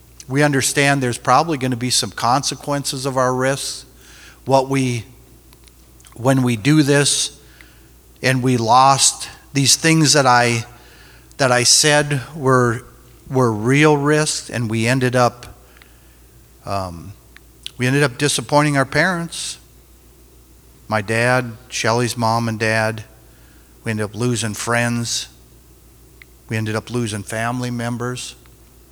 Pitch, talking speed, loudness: 120 Hz, 125 wpm, -17 LUFS